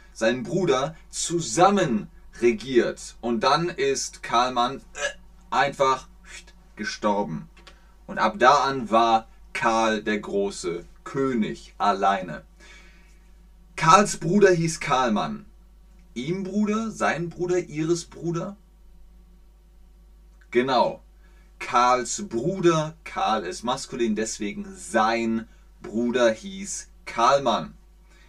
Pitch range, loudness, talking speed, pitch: 160-190 Hz, -24 LUFS, 90 wpm, 185 Hz